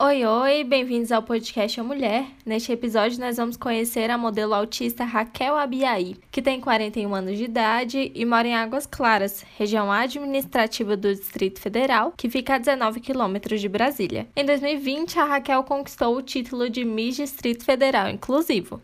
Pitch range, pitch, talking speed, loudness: 220-270 Hz, 240 Hz, 165 wpm, -23 LUFS